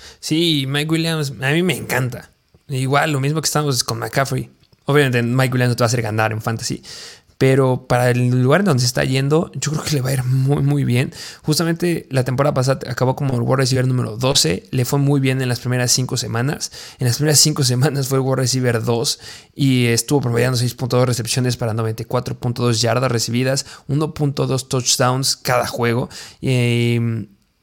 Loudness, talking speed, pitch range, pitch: -18 LUFS, 190 wpm, 120-140 Hz, 130 Hz